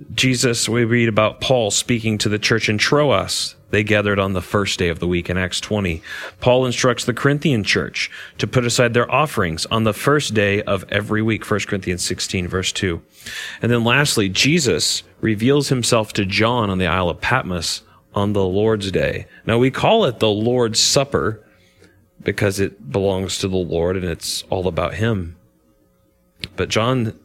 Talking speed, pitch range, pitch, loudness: 180 wpm, 95-120 Hz, 105 Hz, -18 LUFS